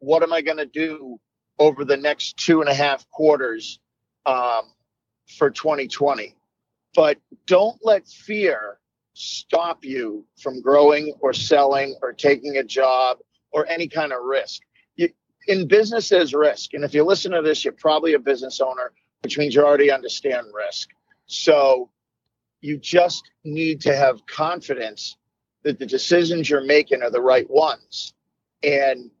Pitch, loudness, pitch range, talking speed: 150 Hz, -20 LUFS, 135-165 Hz, 155 wpm